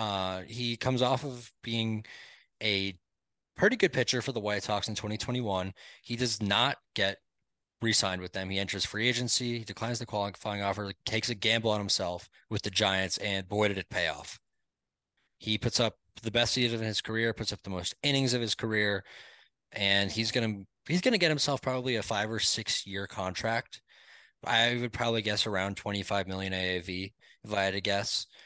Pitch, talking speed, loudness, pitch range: 105 Hz, 195 wpm, -30 LUFS, 100-115 Hz